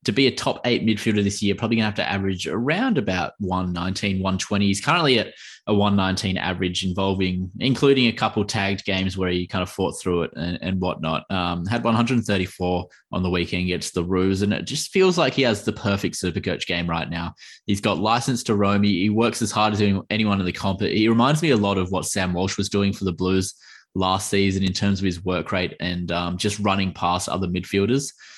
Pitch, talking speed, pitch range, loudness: 95 Hz, 225 wpm, 90-105 Hz, -22 LUFS